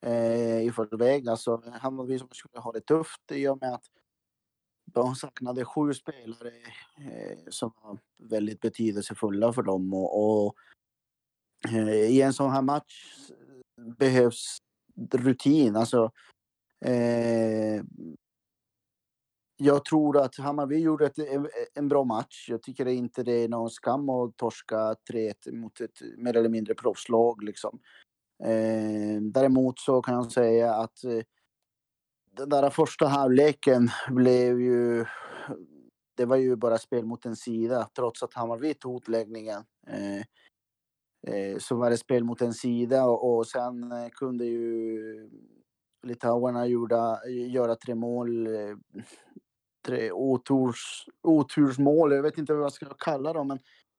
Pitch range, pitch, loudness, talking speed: 115-135 Hz, 120 Hz, -27 LUFS, 130 wpm